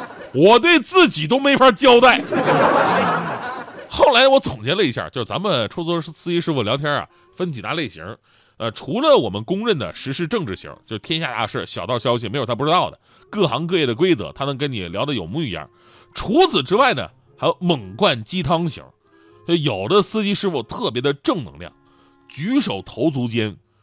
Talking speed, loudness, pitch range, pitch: 285 characters per minute, -18 LUFS, 120-195 Hz, 160 Hz